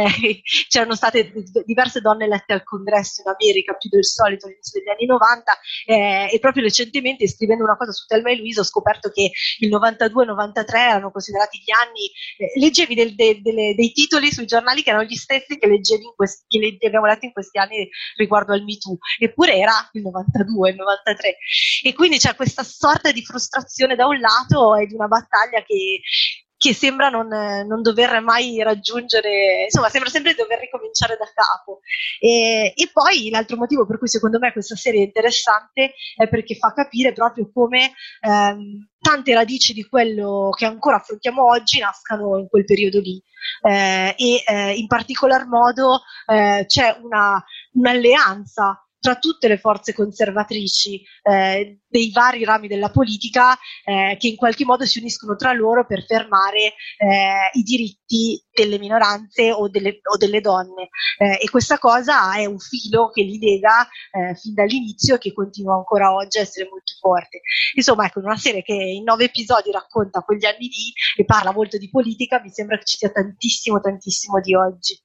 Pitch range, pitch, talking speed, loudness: 205-245 Hz, 220 Hz, 180 wpm, -17 LUFS